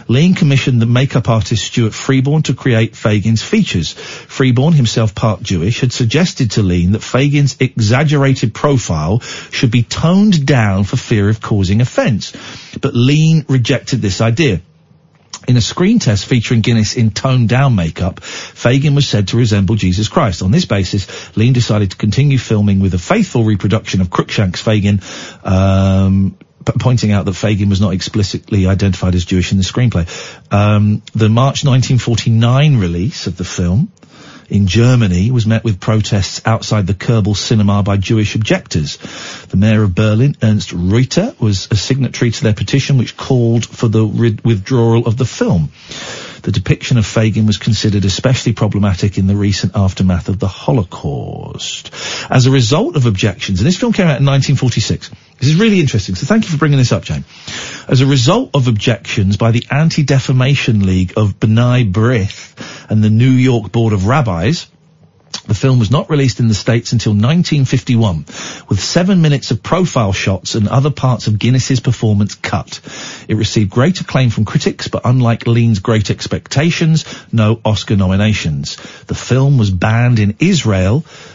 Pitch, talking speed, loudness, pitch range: 115 Hz, 165 wpm, -13 LUFS, 105-130 Hz